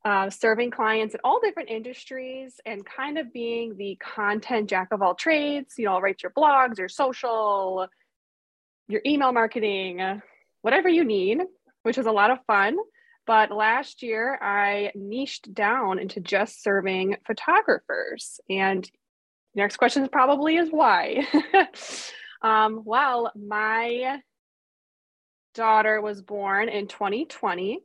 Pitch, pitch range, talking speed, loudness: 225 Hz, 200-265 Hz, 130 wpm, -24 LUFS